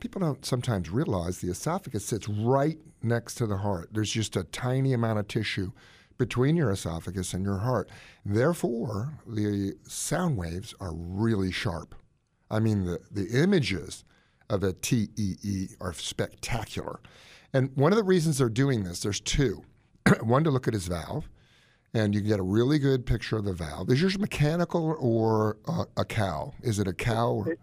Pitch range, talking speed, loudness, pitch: 100-130 Hz, 180 wpm, -28 LUFS, 115 Hz